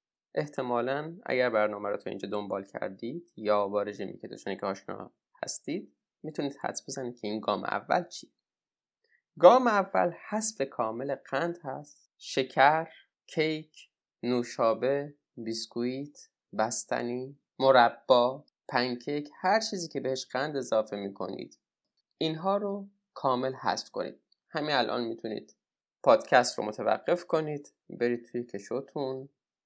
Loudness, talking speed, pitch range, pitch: -30 LUFS, 115 wpm, 115-155 Hz, 135 Hz